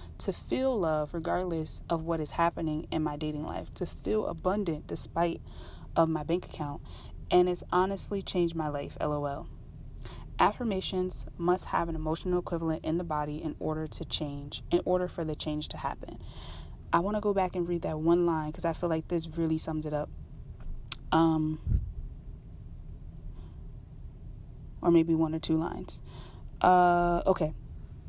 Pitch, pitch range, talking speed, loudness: 160 Hz, 150-175 Hz, 160 wpm, -30 LUFS